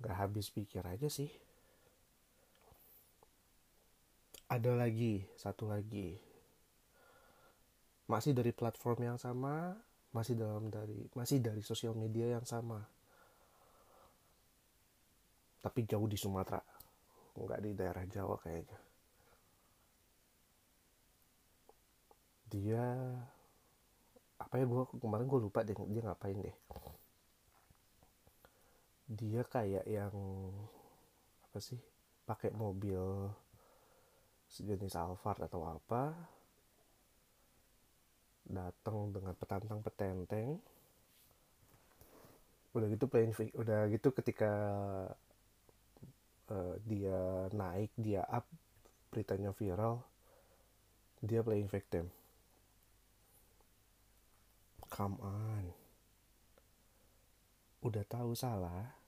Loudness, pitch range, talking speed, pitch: -41 LUFS, 95-115 Hz, 80 wpm, 105 Hz